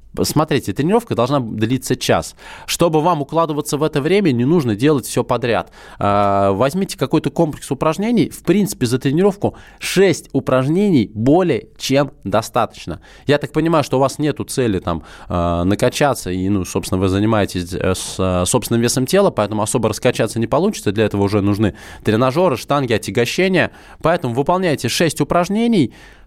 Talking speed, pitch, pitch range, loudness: 145 wpm, 130 Hz, 105-155 Hz, -17 LUFS